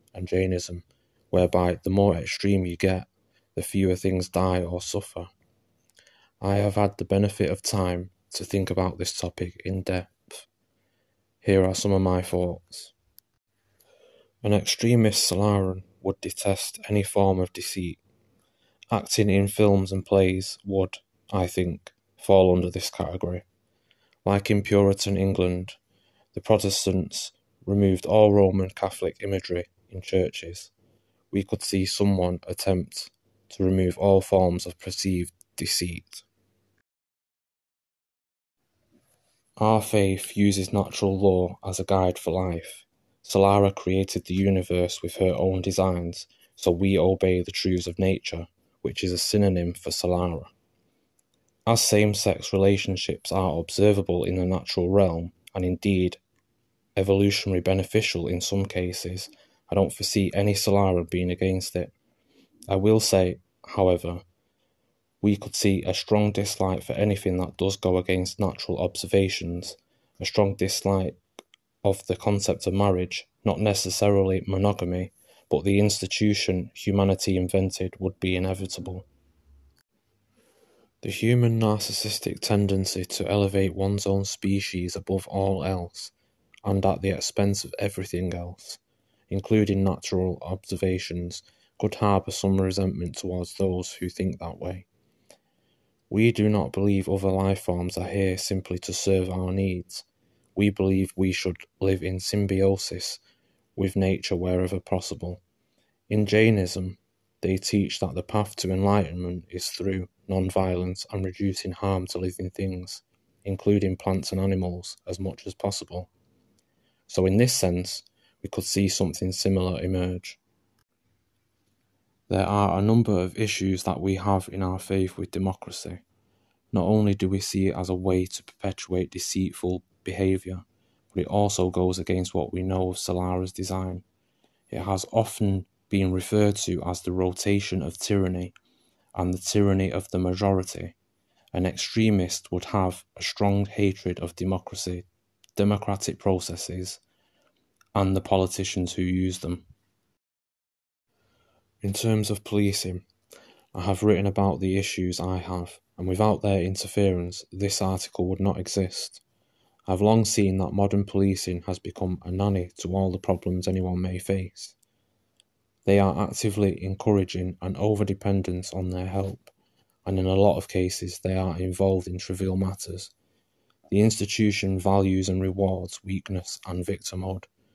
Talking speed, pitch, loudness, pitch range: 135 wpm, 95 Hz, -25 LUFS, 90-100 Hz